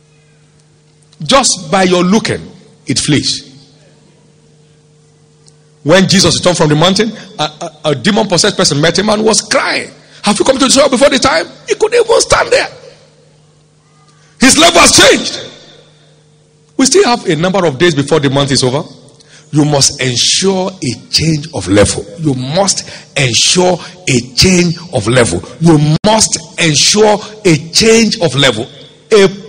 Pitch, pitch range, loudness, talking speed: 155 Hz, 150-195 Hz, -9 LUFS, 155 wpm